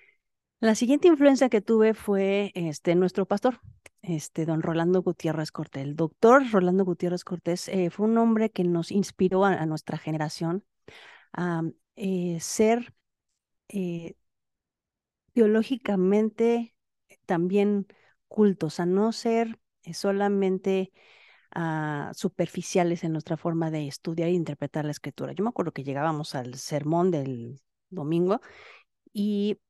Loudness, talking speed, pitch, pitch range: -26 LUFS, 130 wpm, 180 Hz, 165-205 Hz